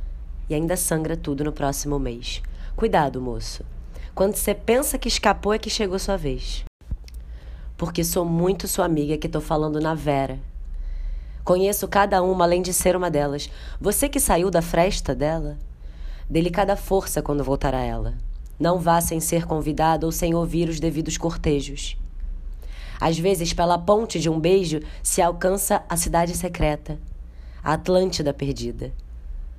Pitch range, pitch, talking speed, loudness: 115-180 Hz, 160 Hz, 150 wpm, -23 LUFS